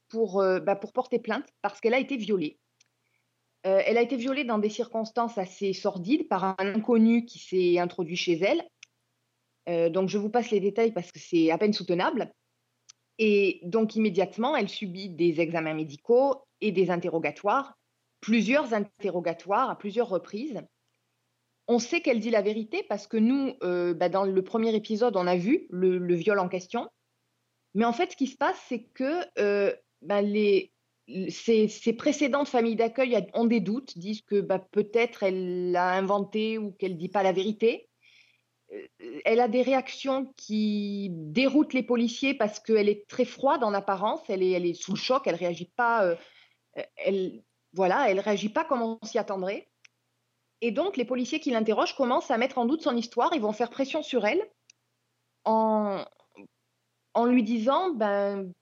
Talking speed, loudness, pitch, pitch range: 175 wpm, -27 LUFS, 220 Hz, 195-250 Hz